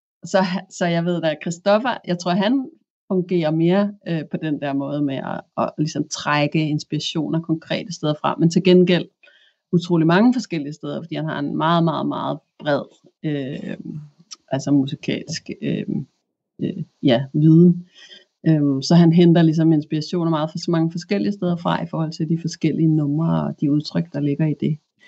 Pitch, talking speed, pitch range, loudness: 165 Hz, 180 wpm, 150-180 Hz, -20 LUFS